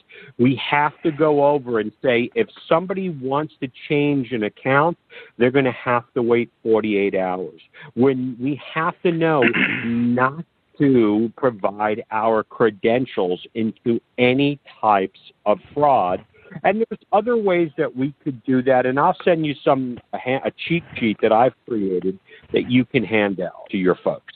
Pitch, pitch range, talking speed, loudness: 130 Hz, 115-150 Hz, 165 wpm, -20 LUFS